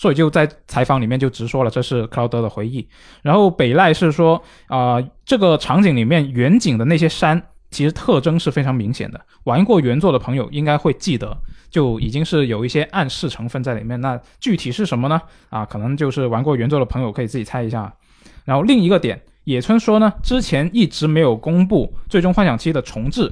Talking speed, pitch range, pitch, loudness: 325 characters per minute, 125-165 Hz, 145 Hz, -17 LUFS